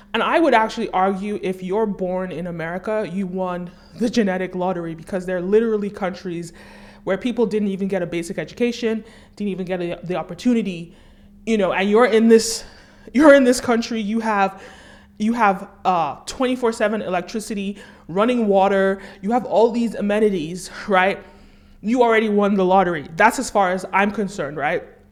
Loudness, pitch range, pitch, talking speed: -20 LUFS, 185-225 Hz, 200 Hz, 170 wpm